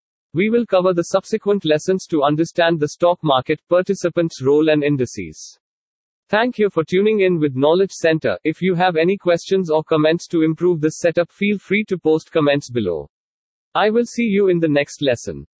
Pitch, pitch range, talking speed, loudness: 170 Hz, 150-190 Hz, 185 wpm, -18 LUFS